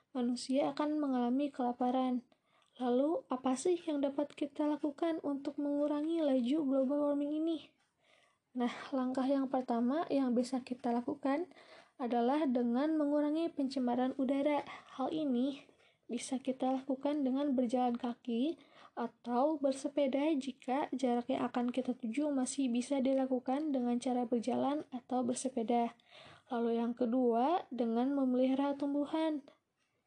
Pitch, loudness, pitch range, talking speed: 265 Hz, -35 LUFS, 250-295 Hz, 120 wpm